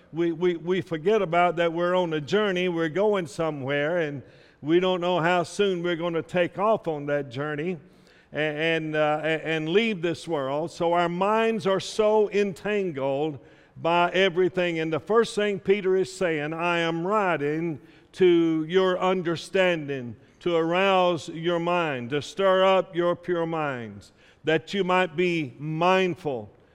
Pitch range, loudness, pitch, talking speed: 155-185 Hz, -25 LUFS, 170 Hz, 155 wpm